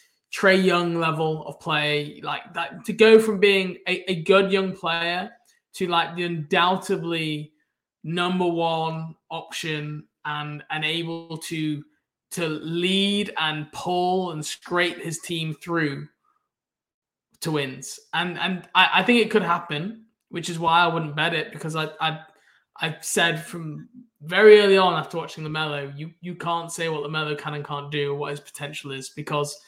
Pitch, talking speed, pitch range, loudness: 165 Hz, 170 wpm, 155-180 Hz, -23 LUFS